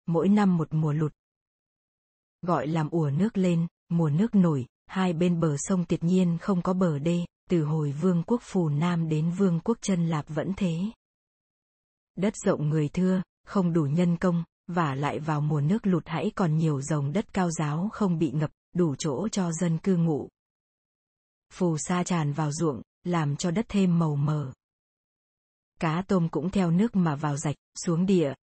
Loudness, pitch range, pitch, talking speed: -27 LUFS, 155-185 Hz, 170 Hz, 185 wpm